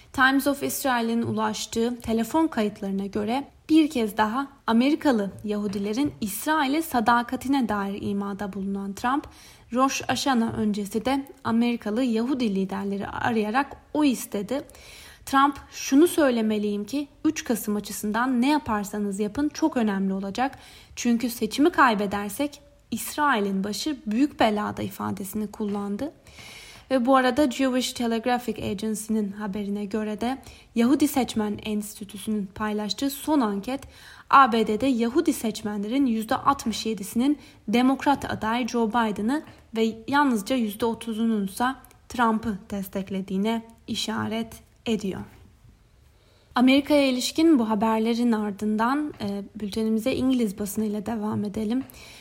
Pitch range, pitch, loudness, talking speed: 210-270 Hz, 230 Hz, -25 LUFS, 105 wpm